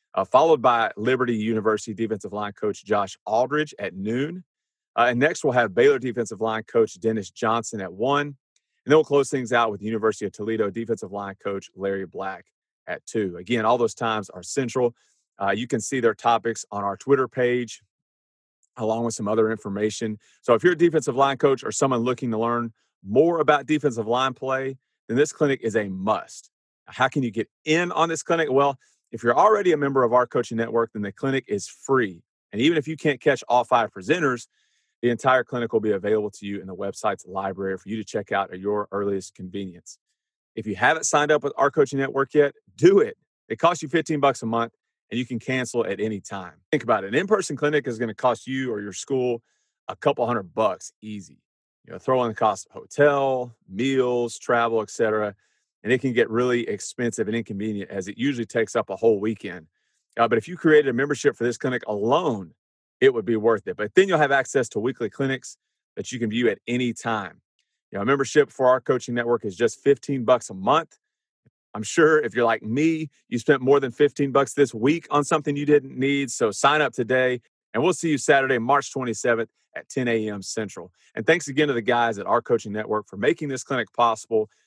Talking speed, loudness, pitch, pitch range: 215 wpm, -23 LUFS, 120 Hz, 110-140 Hz